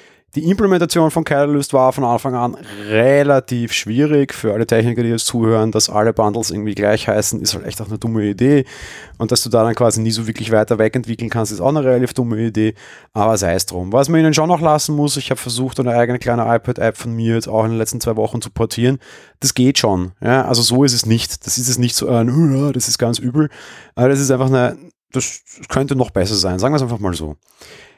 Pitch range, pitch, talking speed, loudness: 110-135 Hz, 120 Hz, 240 wpm, -16 LUFS